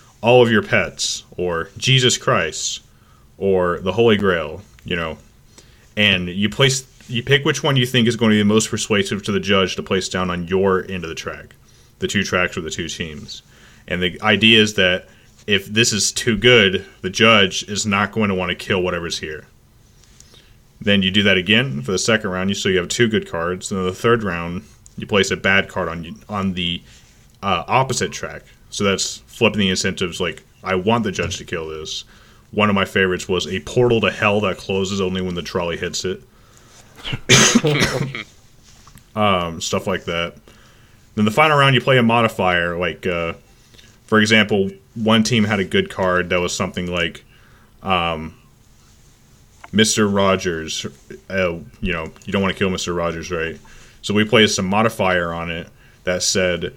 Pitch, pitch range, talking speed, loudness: 100 Hz, 90-115 Hz, 190 wpm, -18 LUFS